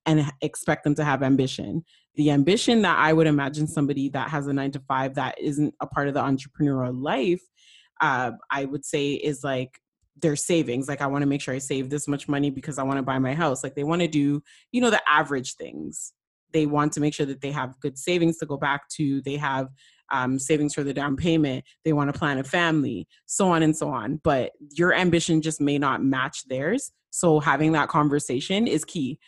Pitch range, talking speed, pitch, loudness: 135-155 Hz, 225 wpm, 145 Hz, -24 LUFS